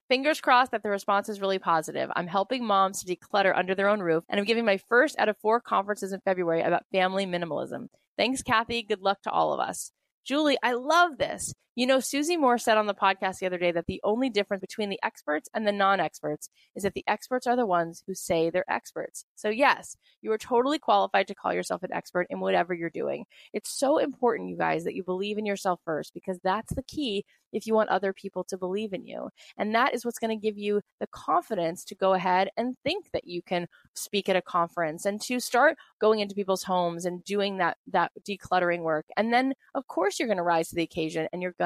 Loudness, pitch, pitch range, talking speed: -27 LUFS, 200 Hz, 180-230 Hz, 235 wpm